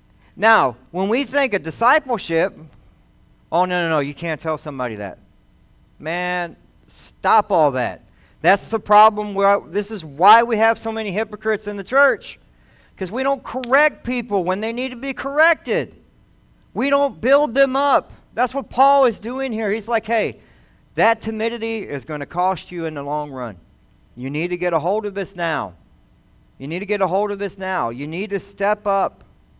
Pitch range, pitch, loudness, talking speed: 170-235 Hz, 205 Hz, -19 LUFS, 190 wpm